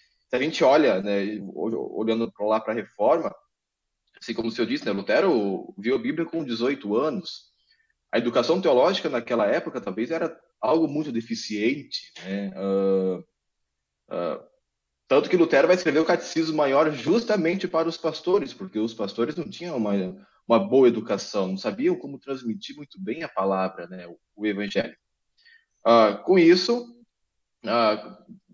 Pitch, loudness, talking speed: 135 Hz, -24 LUFS, 155 wpm